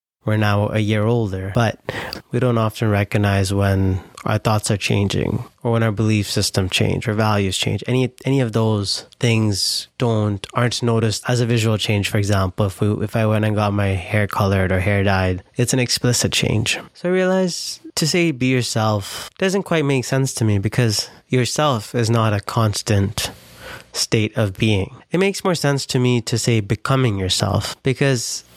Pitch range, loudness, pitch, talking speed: 105-125 Hz, -19 LUFS, 110 Hz, 185 wpm